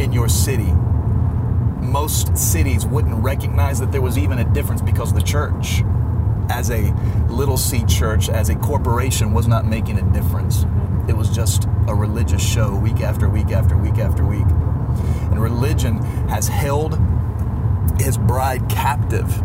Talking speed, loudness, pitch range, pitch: 150 wpm, -18 LUFS, 95-110 Hz, 105 Hz